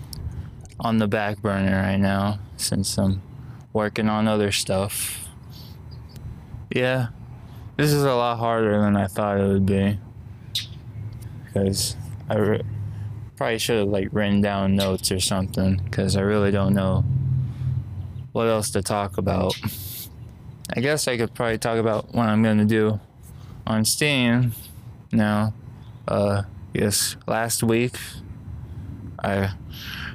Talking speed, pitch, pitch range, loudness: 130 wpm, 110 Hz, 100-115 Hz, -23 LUFS